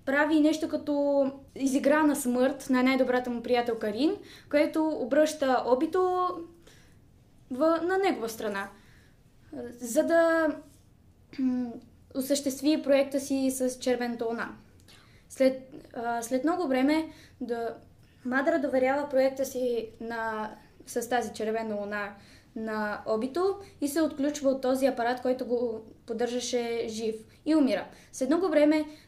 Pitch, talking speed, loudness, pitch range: 265 Hz, 120 wpm, -28 LUFS, 240-300 Hz